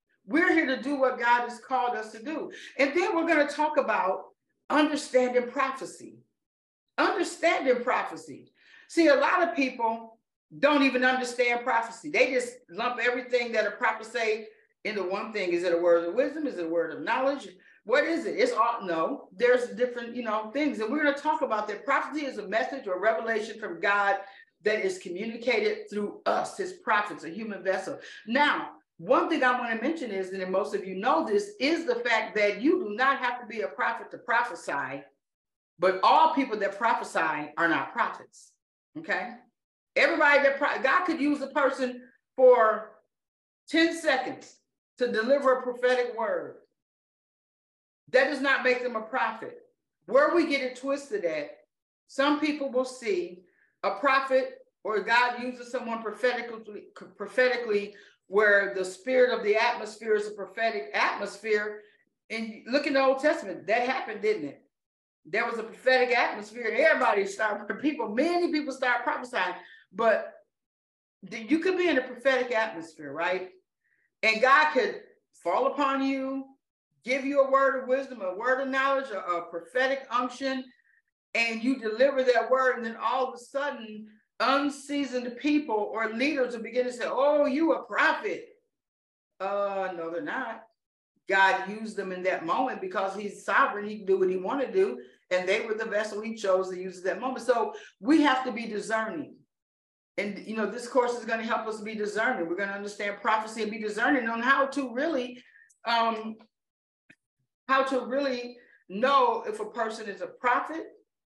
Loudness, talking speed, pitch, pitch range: -27 LUFS, 175 wpm, 245 Hz, 210-275 Hz